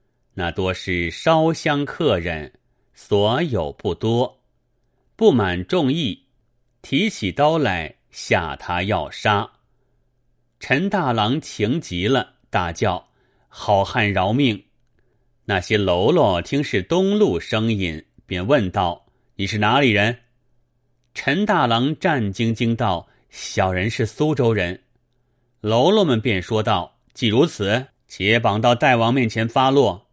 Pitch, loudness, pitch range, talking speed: 120 Hz, -20 LUFS, 100-125 Hz, 165 characters per minute